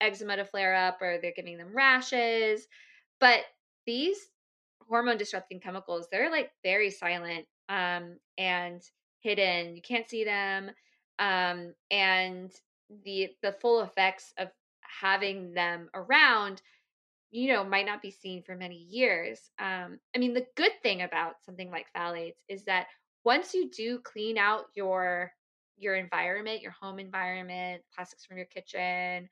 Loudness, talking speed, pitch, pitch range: -29 LUFS, 145 wpm, 190 Hz, 180-215 Hz